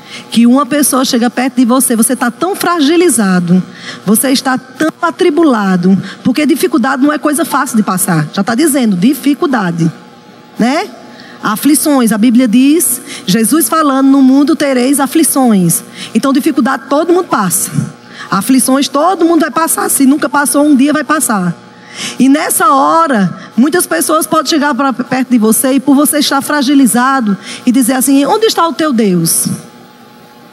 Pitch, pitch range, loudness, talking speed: 270 Hz, 240-305 Hz, -10 LUFS, 155 wpm